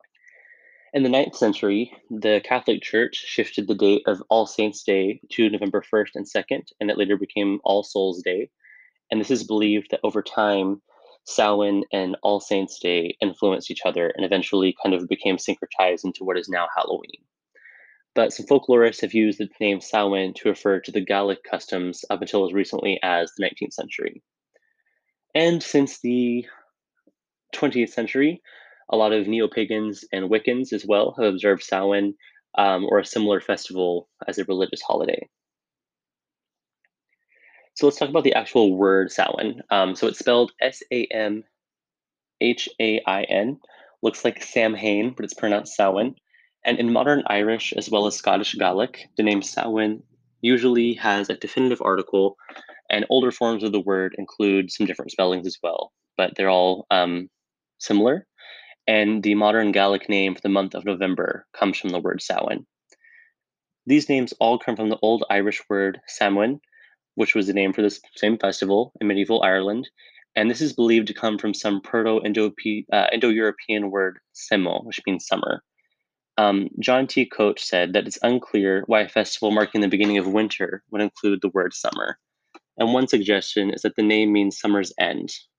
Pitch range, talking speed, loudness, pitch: 100-115 Hz, 170 wpm, -22 LUFS, 105 Hz